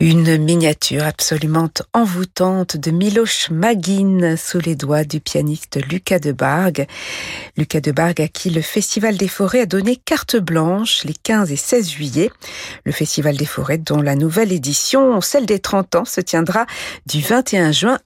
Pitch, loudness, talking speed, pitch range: 175 Hz, -17 LUFS, 165 wpm, 155-210 Hz